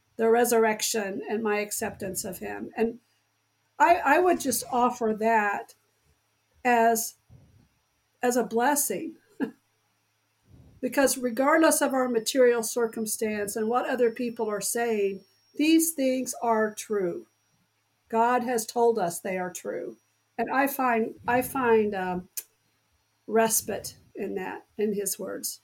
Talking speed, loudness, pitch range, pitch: 125 wpm, -26 LUFS, 210-250 Hz, 230 Hz